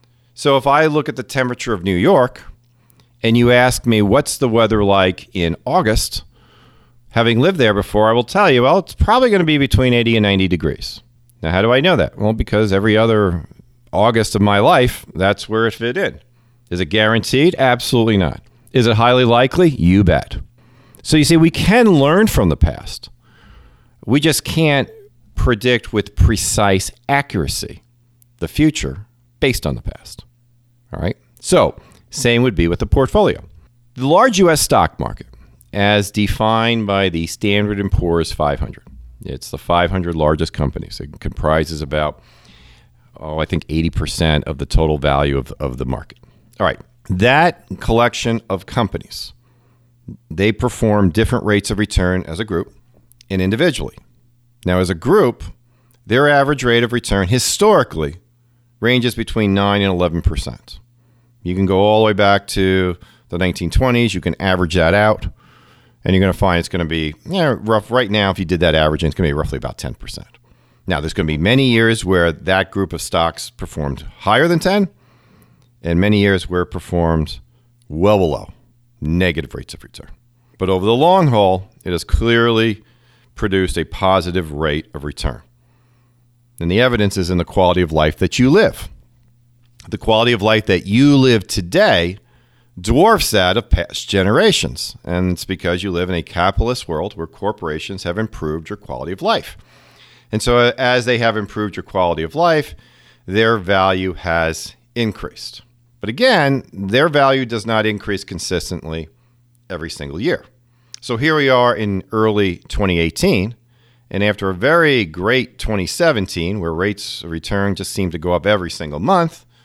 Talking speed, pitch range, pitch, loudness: 170 wpm, 90-120 Hz, 105 Hz, -16 LUFS